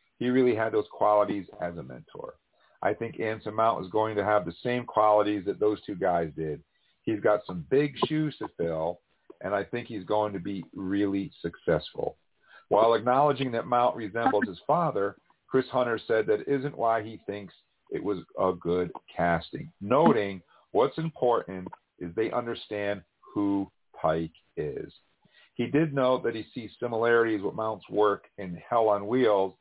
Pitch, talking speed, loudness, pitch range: 110 Hz, 170 wpm, -28 LUFS, 100-120 Hz